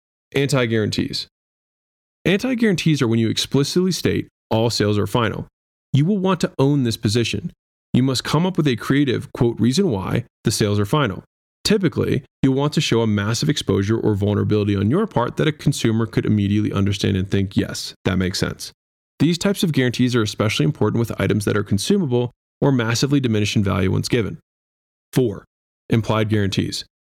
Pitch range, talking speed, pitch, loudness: 100-140 Hz, 175 wpm, 115 Hz, -20 LUFS